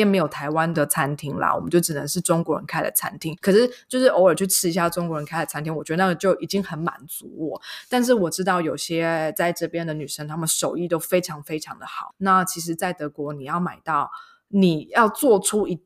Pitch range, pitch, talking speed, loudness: 155-190 Hz, 170 Hz, 335 characters per minute, -22 LUFS